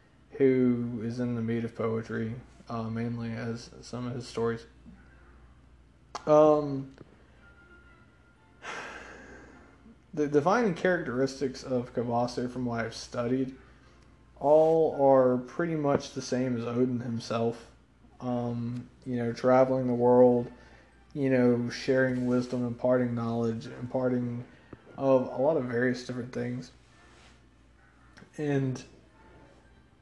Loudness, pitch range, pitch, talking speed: -28 LUFS, 115-130 Hz, 125 Hz, 110 wpm